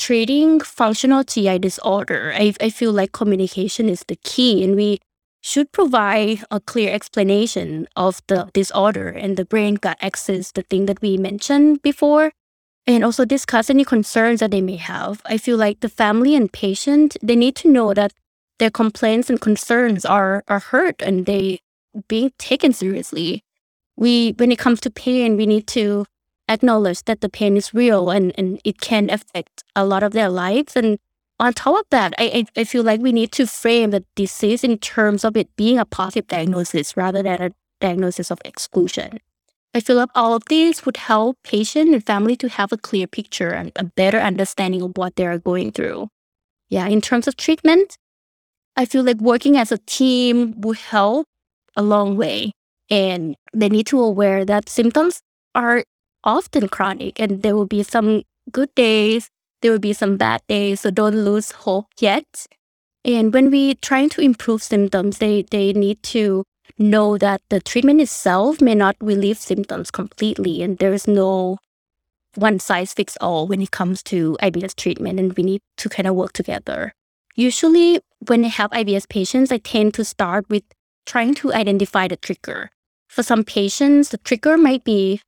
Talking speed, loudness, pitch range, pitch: 180 wpm, -18 LUFS, 195-240 Hz, 215 Hz